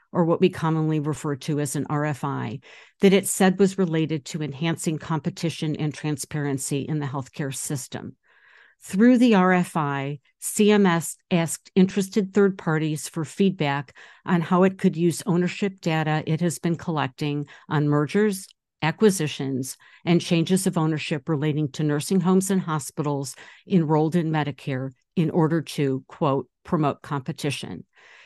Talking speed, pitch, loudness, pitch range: 140 wpm, 160 Hz, -24 LUFS, 145-185 Hz